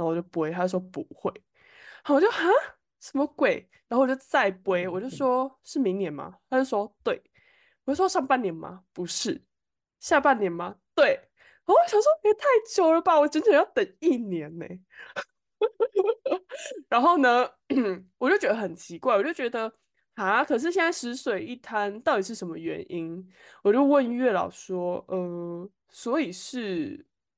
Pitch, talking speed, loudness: 260 Hz, 240 characters per minute, -26 LUFS